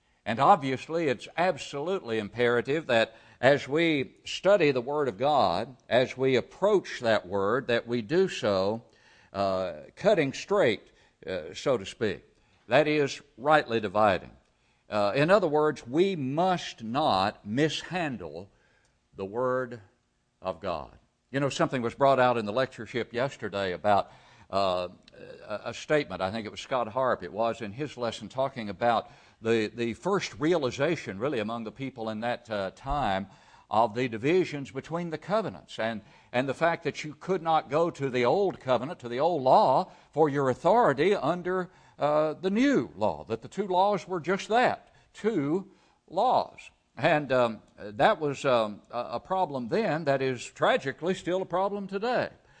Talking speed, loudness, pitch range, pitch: 160 wpm, -28 LUFS, 115-160 Hz, 130 Hz